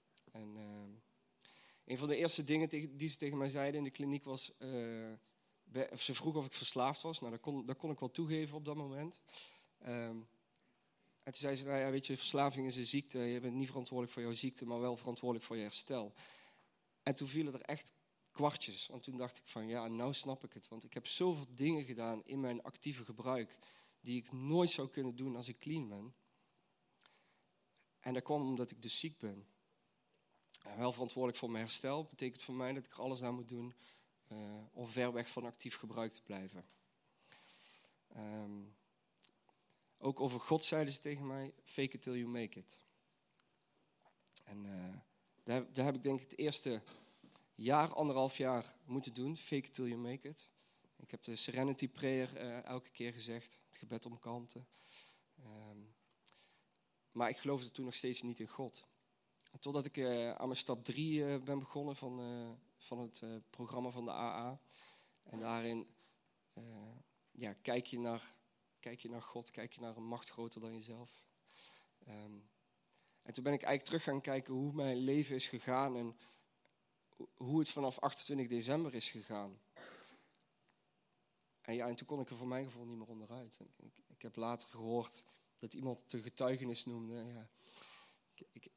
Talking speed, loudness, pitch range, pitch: 185 wpm, -42 LUFS, 115-140 Hz, 125 Hz